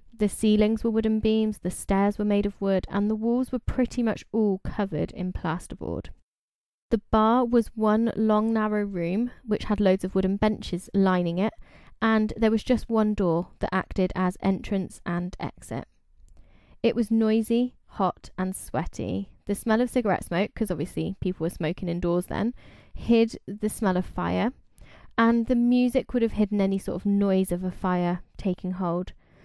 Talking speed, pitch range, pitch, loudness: 175 wpm, 185-225 Hz, 205 Hz, -26 LUFS